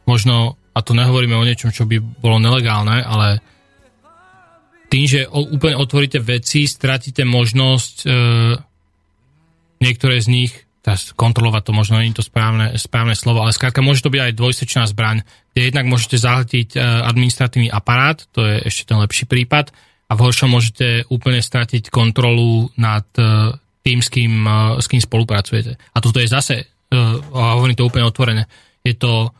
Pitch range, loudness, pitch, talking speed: 115-130 Hz, -15 LUFS, 120 Hz, 165 wpm